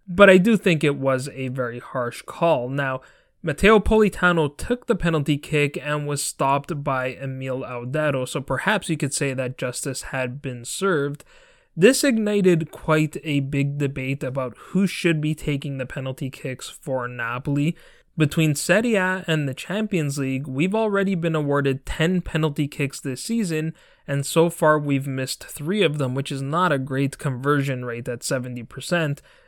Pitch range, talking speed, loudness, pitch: 135-170 Hz, 165 wpm, -22 LUFS, 145 Hz